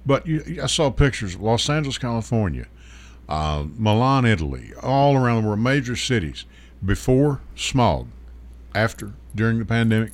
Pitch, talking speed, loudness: 115 Hz, 140 wpm, -21 LUFS